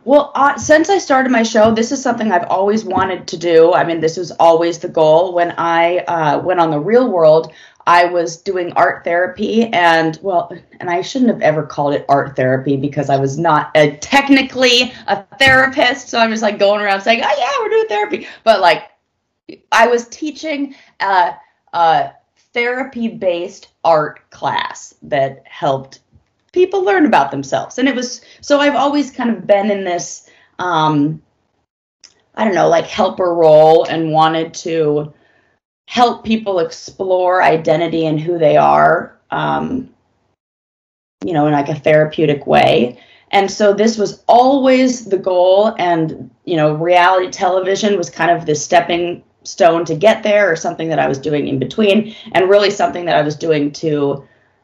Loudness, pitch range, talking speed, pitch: -14 LUFS, 160-225 Hz, 170 wpm, 180 Hz